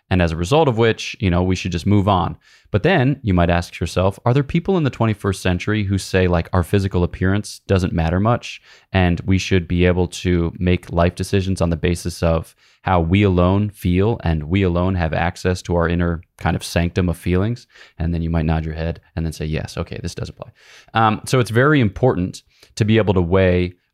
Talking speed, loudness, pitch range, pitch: 225 wpm, -19 LUFS, 85-105 Hz, 90 Hz